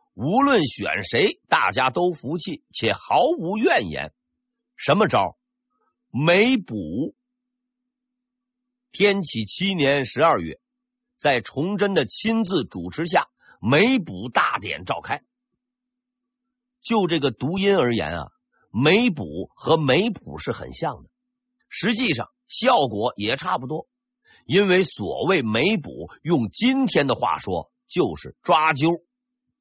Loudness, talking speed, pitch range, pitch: -22 LUFS, 170 characters per minute, 175-250 Hz, 245 Hz